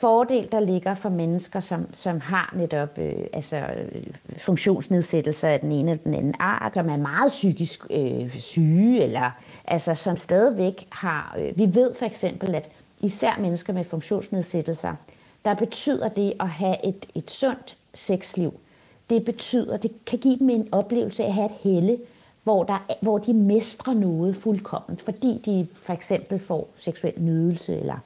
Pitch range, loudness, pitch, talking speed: 170-220 Hz, -24 LUFS, 195 Hz, 165 wpm